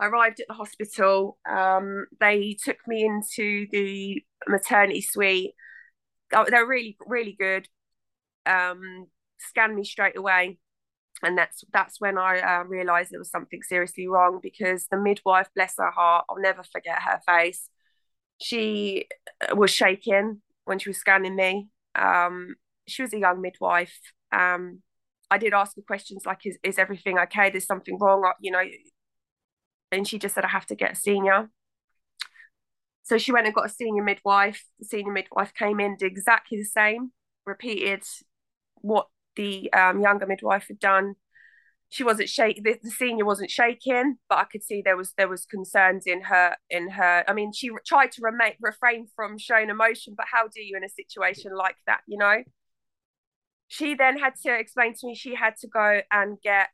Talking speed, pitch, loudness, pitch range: 180 wpm, 200 Hz, -24 LUFS, 190-225 Hz